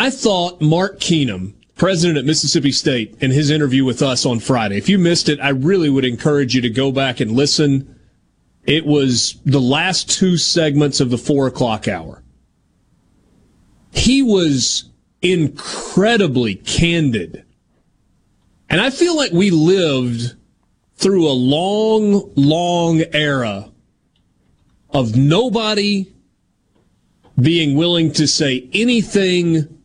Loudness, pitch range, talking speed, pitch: -15 LUFS, 130-180 Hz, 125 wpm, 150 Hz